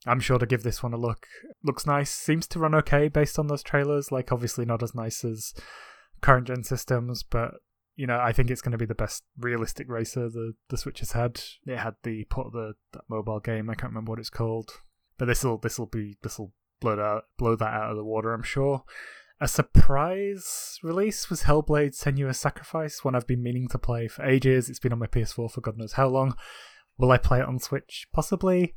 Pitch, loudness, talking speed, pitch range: 125 Hz, -27 LUFS, 225 wpm, 115-140 Hz